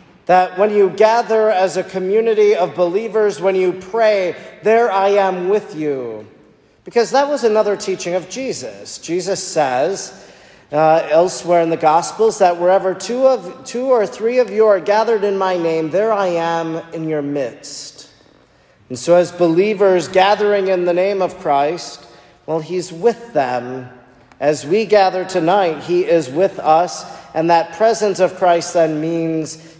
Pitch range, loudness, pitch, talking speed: 165-205 Hz, -16 LUFS, 185 Hz, 160 wpm